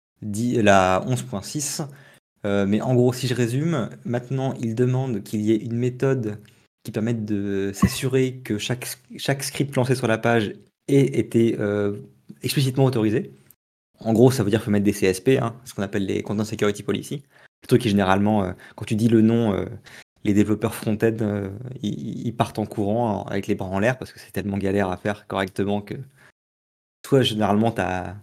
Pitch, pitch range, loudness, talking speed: 110 Hz, 100-125 Hz, -23 LUFS, 190 wpm